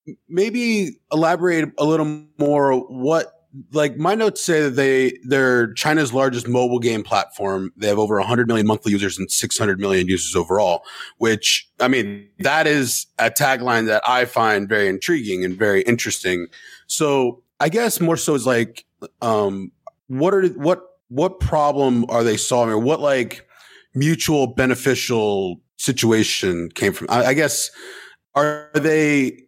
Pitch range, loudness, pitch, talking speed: 110-155 Hz, -19 LUFS, 130 Hz, 150 wpm